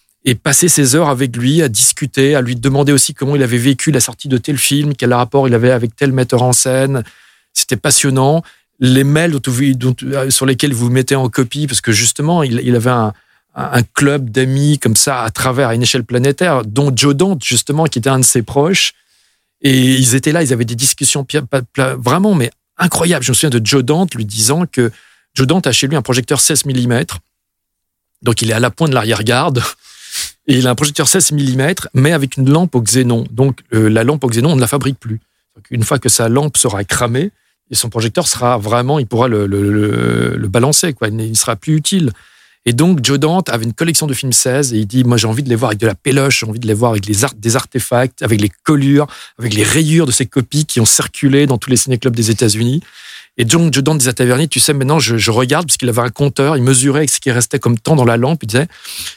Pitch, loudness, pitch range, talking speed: 130 Hz, -12 LUFS, 120-145 Hz, 240 wpm